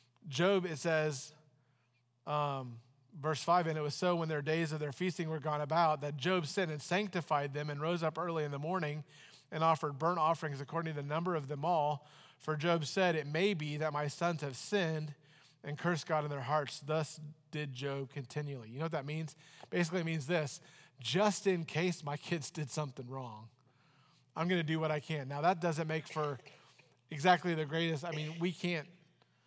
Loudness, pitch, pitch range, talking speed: -36 LUFS, 155 Hz, 145-170 Hz, 205 wpm